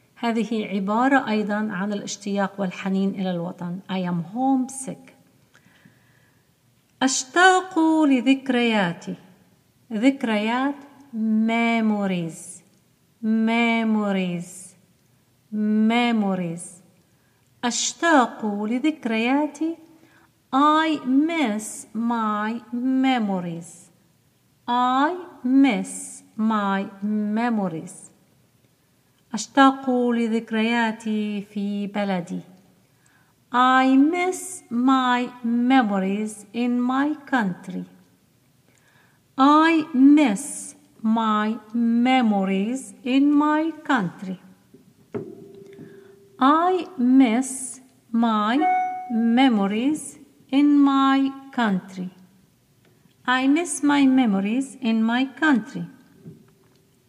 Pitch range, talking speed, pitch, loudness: 195-265 Hz, 60 wpm, 230 Hz, -21 LUFS